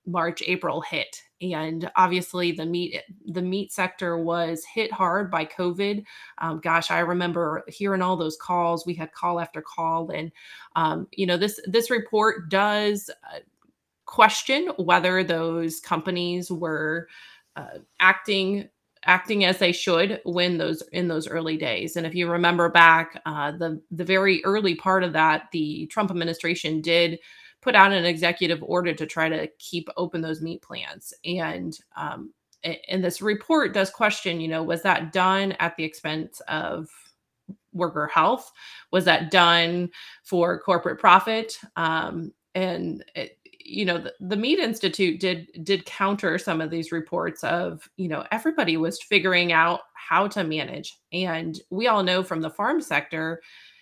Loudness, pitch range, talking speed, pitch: -23 LUFS, 165-190 Hz, 155 wpm, 175 Hz